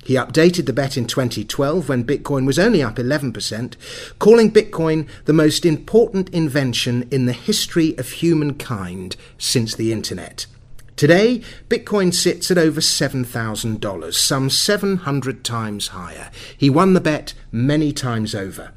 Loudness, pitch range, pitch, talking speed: -18 LUFS, 120-165 Hz, 135 Hz, 140 wpm